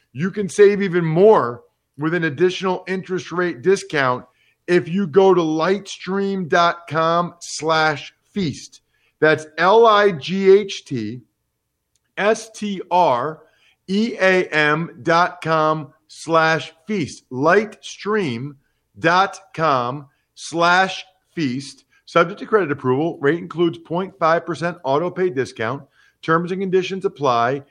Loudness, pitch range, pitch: -19 LUFS, 155-190 Hz, 170 Hz